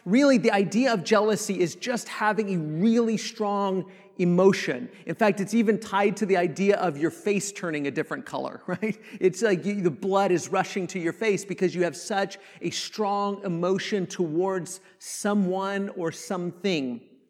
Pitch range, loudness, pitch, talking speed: 180-205 Hz, -26 LUFS, 195 Hz, 170 wpm